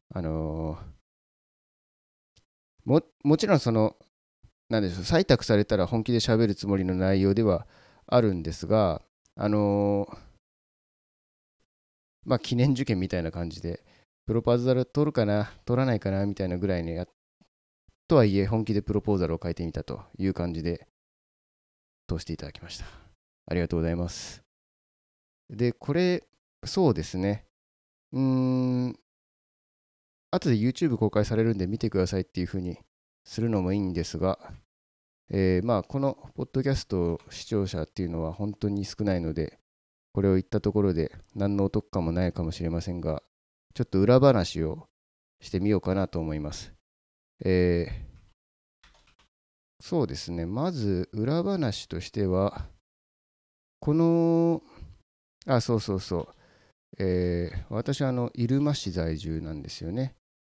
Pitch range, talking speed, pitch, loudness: 80-115 Hz, 280 characters per minute, 95 Hz, -27 LUFS